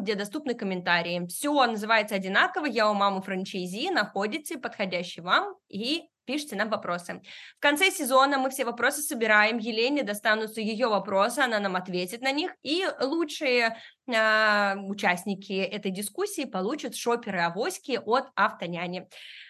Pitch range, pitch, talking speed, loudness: 195-270 Hz, 220 Hz, 135 wpm, -27 LUFS